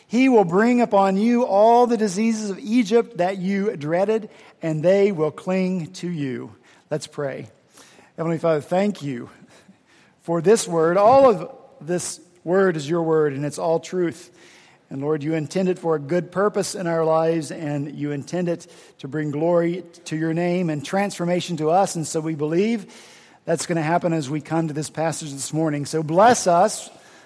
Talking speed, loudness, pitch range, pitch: 185 wpm, -21 LUFS, 160-195 Hz, 170 Hz